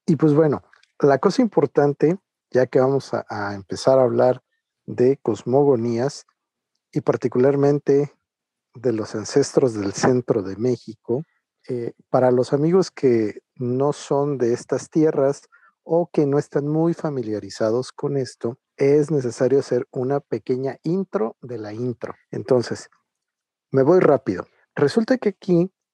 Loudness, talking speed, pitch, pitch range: -21 LUFS, 135 wpm, 135 Hz, 125-155 Hz